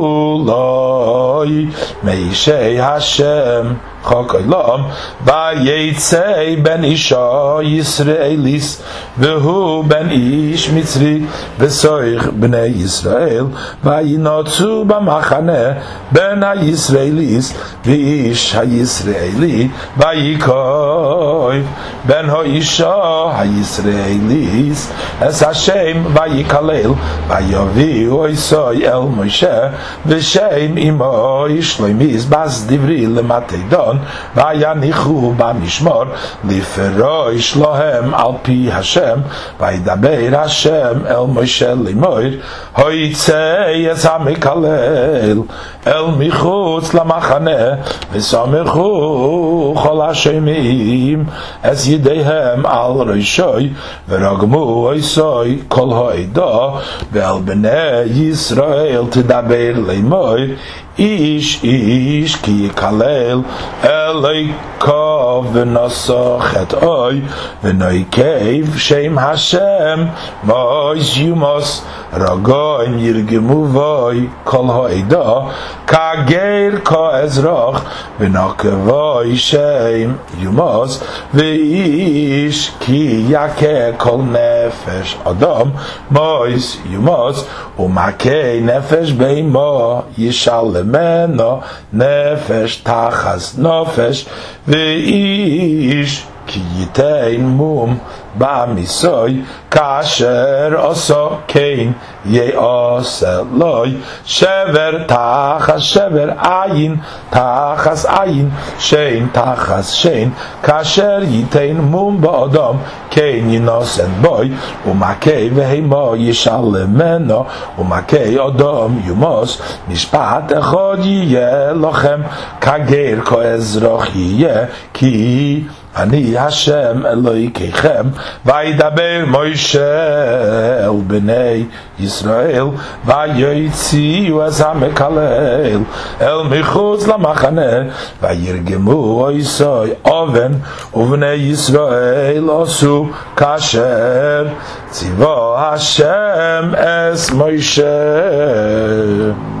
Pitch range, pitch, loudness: 120-155 Hz, 140 Hz, -12 LUFS